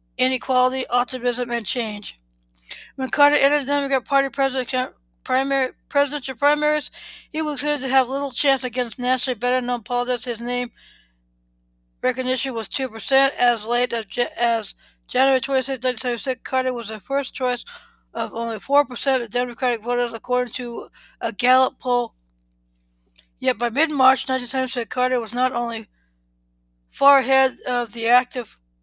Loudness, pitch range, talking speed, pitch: -21 LUFS, 230-265 Hz, 140 wpm, 250 Hz